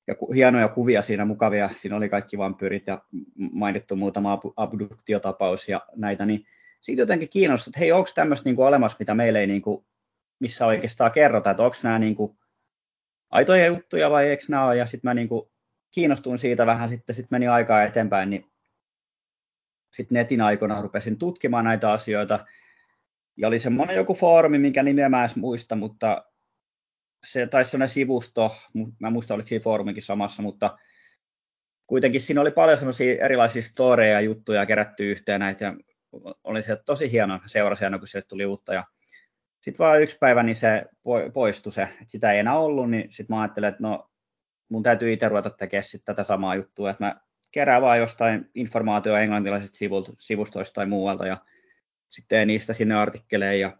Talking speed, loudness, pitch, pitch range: 165 wpm, -23 LUFS, 110 Hz, 100-125 Hz